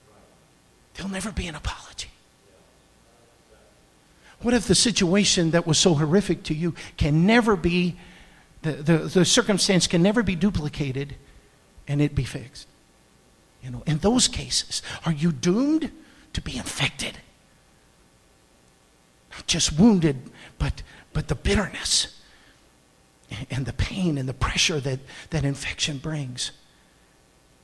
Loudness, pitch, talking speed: -23 LUFS, 150 Hz, 130 wpm